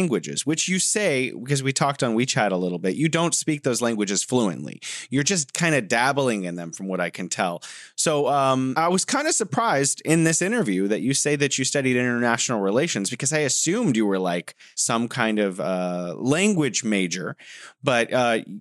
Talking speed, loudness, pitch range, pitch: 205 wpm, -22 LUFS, 105-150 Hz, 130 Hz